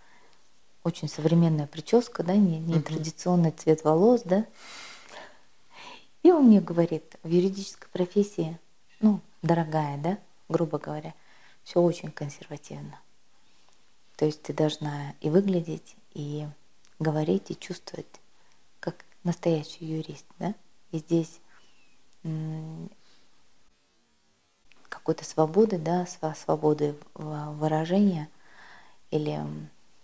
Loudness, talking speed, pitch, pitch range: -27 LUFS, 90 wpm, 165 Hz, 155-185 Hz